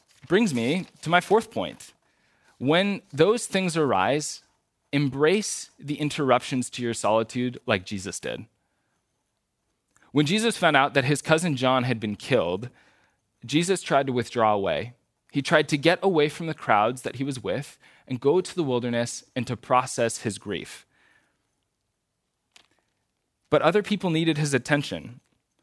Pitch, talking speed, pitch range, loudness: 140 Hz, 150 wpm, 120-160 Hz, -25 LUFS